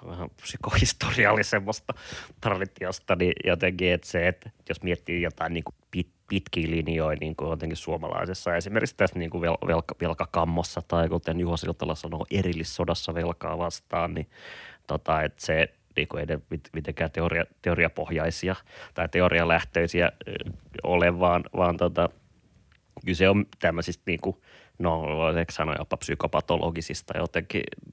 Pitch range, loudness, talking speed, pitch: 80-90 Hz, -27 LUFS, 115 wpm, 85 Hz